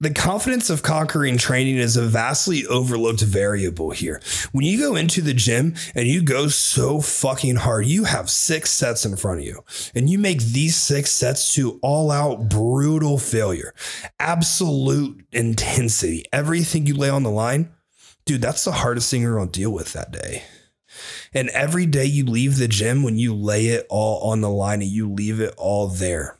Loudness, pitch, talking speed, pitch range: -20 LUFS, 130 Hz, 190 wpm, 110-150 Hz